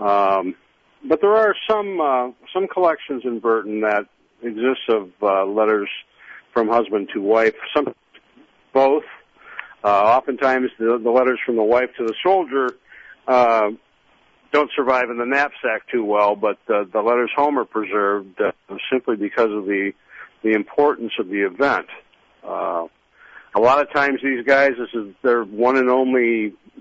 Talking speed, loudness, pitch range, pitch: 155 wpm, -19 LUFS, 105-135 Hz, 120 Hz